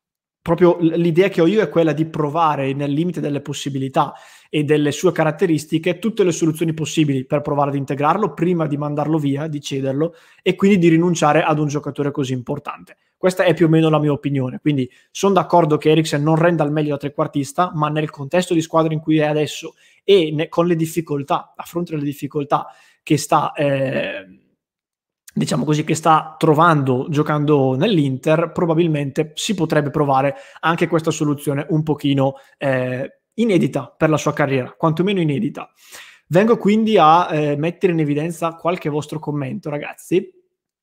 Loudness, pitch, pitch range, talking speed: -18 LUFS, 155 Hz, 145-170 Hz, 170 wpm